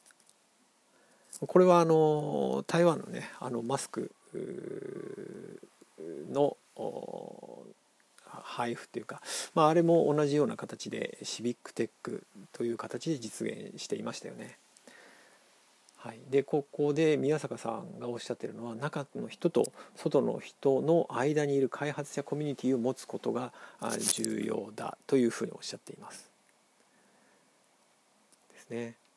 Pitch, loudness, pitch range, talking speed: 145 Hz, -32 LUFS, 130-165 Hz, 265 characters per minute